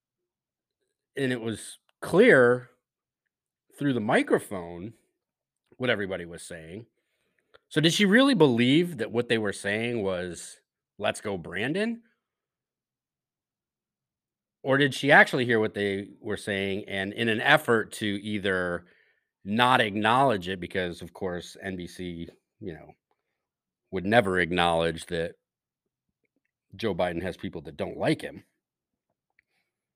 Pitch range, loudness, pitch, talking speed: 95-130 Hz, -25 LUFS, 105 Hz, 120 wpm